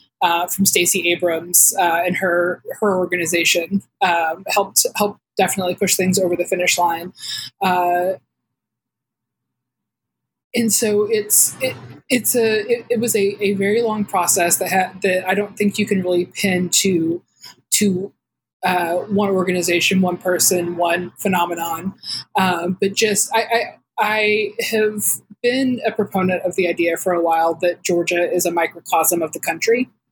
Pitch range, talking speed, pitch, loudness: 175-210 Hz, 155 wpm, 185 Hz, -18 LUFS